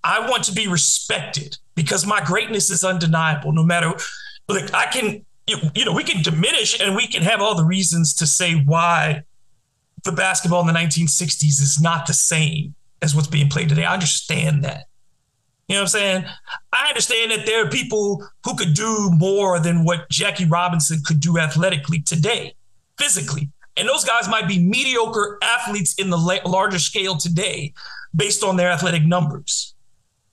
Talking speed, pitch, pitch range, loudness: 175 wpm, 170 Hz, 150-195 Hz, -18 LUFS